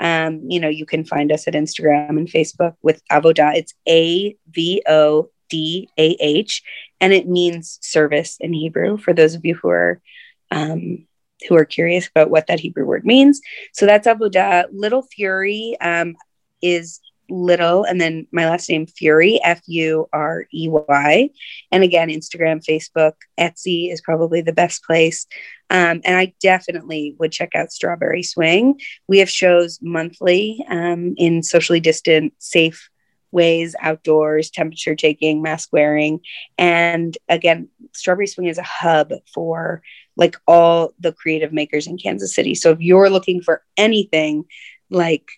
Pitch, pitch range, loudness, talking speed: 165 Hz, 155-180 Hz, -16 LUFS, 150 wpm